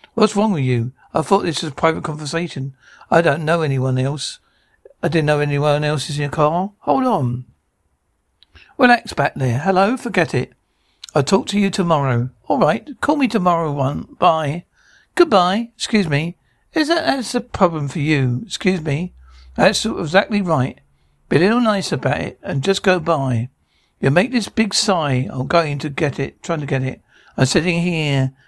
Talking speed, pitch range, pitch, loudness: 185 wpm, 135-195 Hz, 160 Hz, -18 LUFS